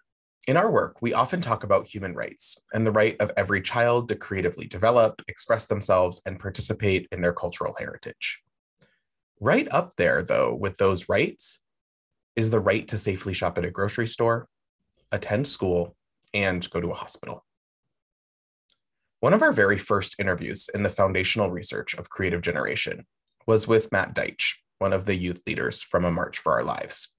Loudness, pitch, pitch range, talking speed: -25 LUFS, 100 Hz, 90-110 Hz, 170 wpm